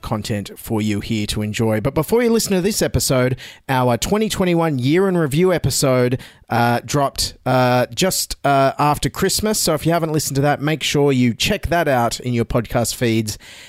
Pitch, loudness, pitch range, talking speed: 135 Hz, -18 LUFS, 120-165 Hz, 190 wpm